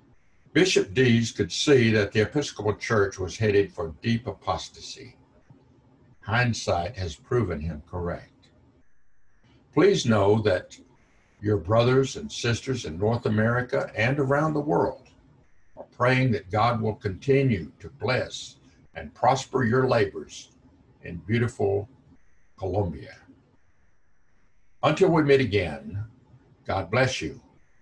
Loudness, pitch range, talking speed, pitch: -25 LUFS, 100-130 Hz, 115 wpm, 110 Hz